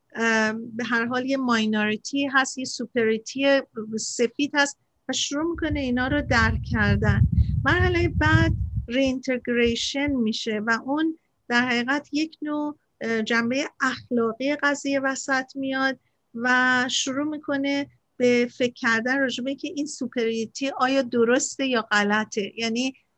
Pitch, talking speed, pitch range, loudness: 250 Hz, 125 wpm, 225-275 Hz, -24 LUFS